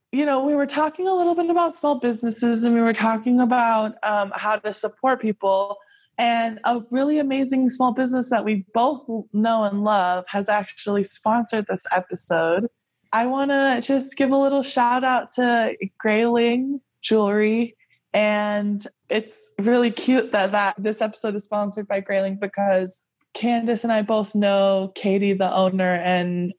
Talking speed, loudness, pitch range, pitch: 160 wpm, -21 LUFS, 205-250 Hz, 225 Hz